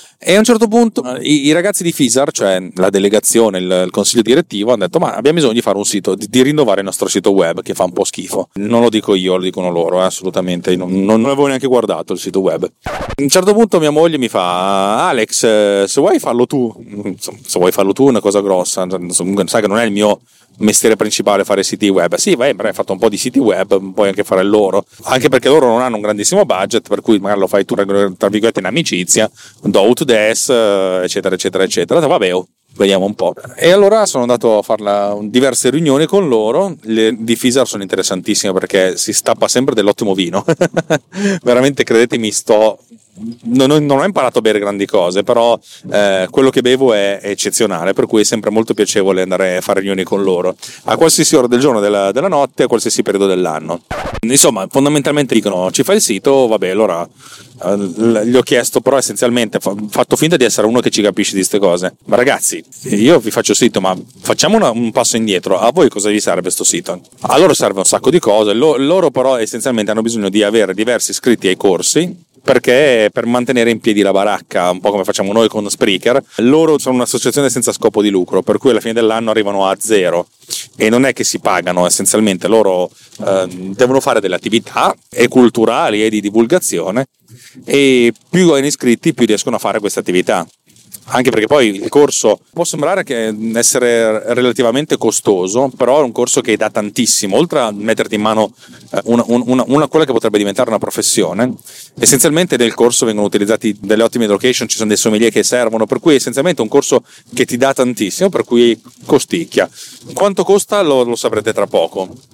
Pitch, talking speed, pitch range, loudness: 115 Hz, 205 wpm, 100-135 Hz, -13 LUFS